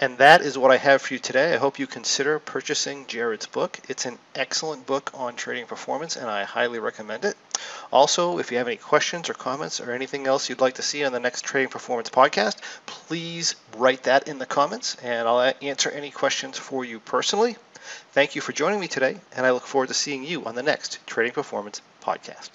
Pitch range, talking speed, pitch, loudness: 125-155 Hz, 220 wpm, 135 Hz, -24 LUFS